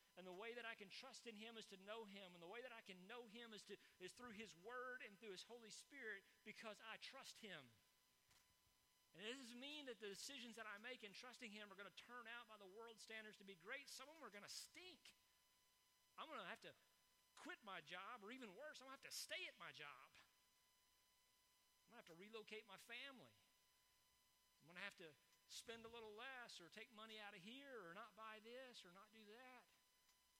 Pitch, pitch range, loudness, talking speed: 220 Hz, 195-245 Hz, -58 LUFS, 235 wpm